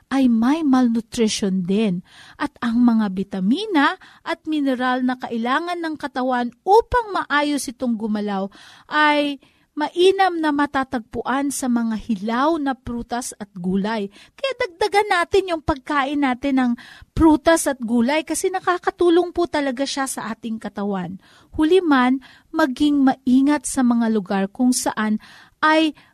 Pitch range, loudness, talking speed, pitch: 235-315 Hz, -20 LUFS, 130 wpm, 270 Hz